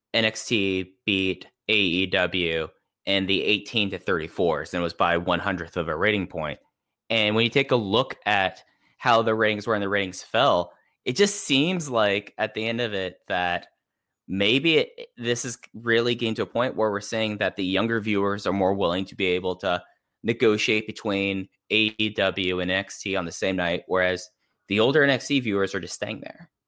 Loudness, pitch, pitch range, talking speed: -24 LUFS, 100 Hz, 95-115 Hz, 185 wpm